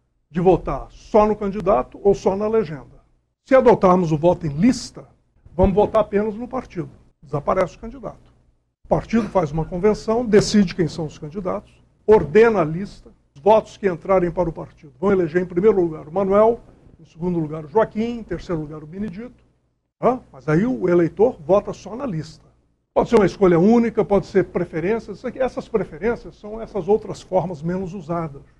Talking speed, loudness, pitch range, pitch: 180 wpm, -20 LUFS, 165-215 Hz, 190 Hz